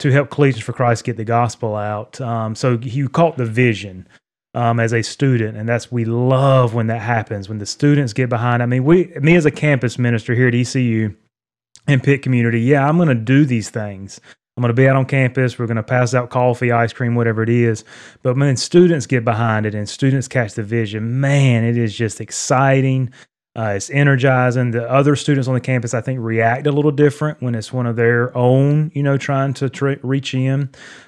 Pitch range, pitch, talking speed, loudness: 115-135 Hz, 125 Hz, 220 wpm, -17 LUFS